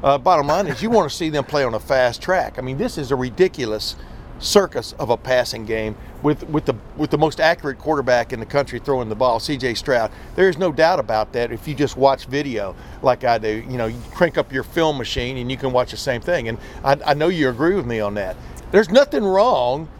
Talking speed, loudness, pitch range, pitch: 250 wpm, -20 LUFS, 120-155 Hz, 135 Hz